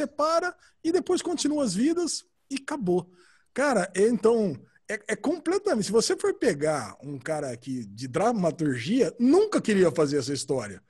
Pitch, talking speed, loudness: 220 Hz, 155 wpm, -26 LUFS